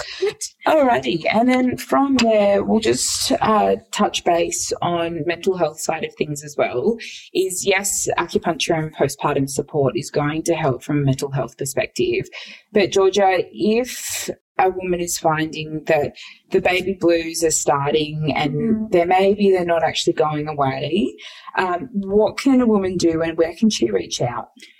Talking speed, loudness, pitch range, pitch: 160 wpm, -19 LUFS, 155-205 Hz, 175 Hz